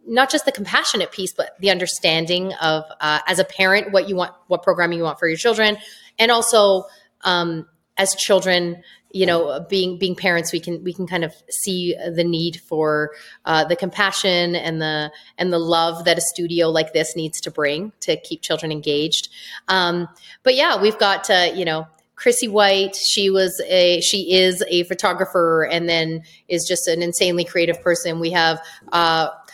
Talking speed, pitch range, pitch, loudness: 185 wpm, 165-190 Hz, 175 Hz, -19 LUFS